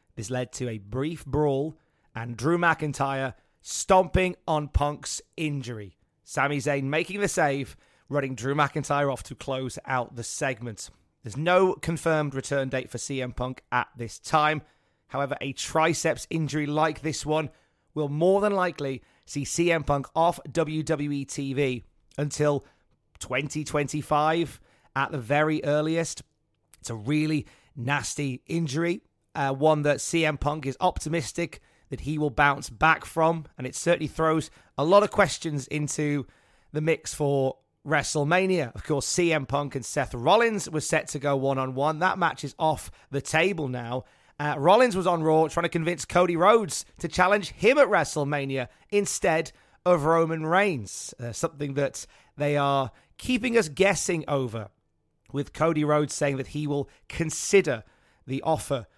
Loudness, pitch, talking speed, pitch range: -26 LUFS, 145 Hz, 155 wpm, 135-160 Hz